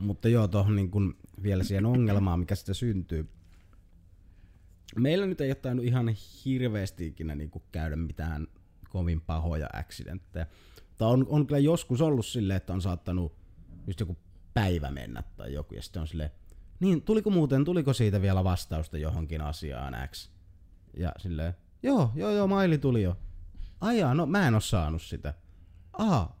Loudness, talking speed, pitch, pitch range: -29 LUFS, 155 wpm, 90 Hz, 85-115 Hz